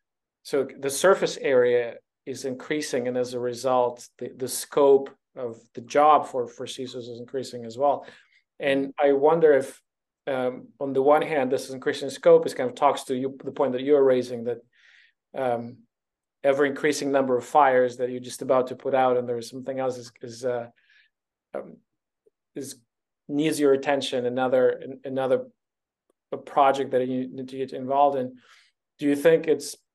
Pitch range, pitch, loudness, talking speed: 125-145 Hz, 135 Hz, -24 LUFS, 175 wpm